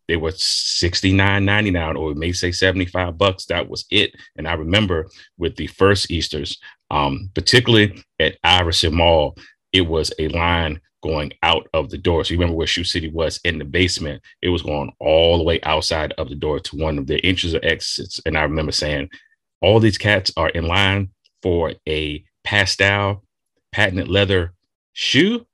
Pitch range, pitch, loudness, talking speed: 80-95 Hz, 90 Hz, -18 LUFS, 180 wpm